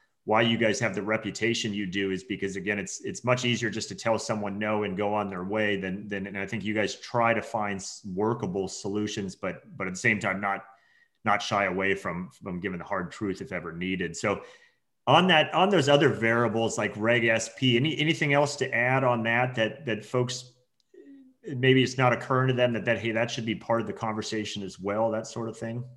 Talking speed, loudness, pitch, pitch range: 225 wpm, -27 LUFS, 110 Hz, 105-125 Hz